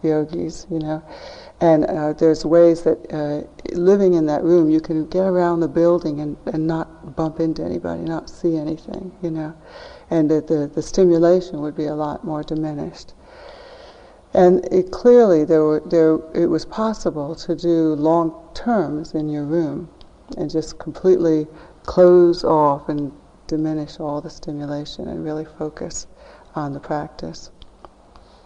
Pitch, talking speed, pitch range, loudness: 160 Hz, 155 wpm, 155-170 Hz, -19 LUFS